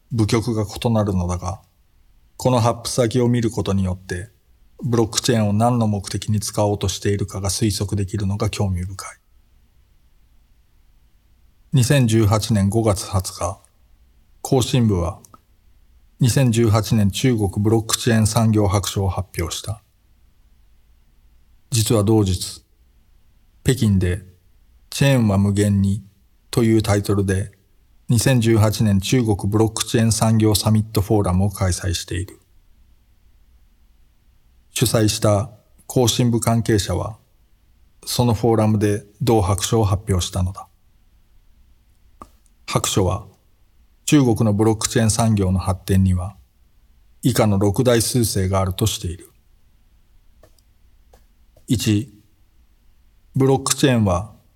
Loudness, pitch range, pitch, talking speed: -19 LUFS, 90-110 Hz, 100 Hz, 230 characters per minute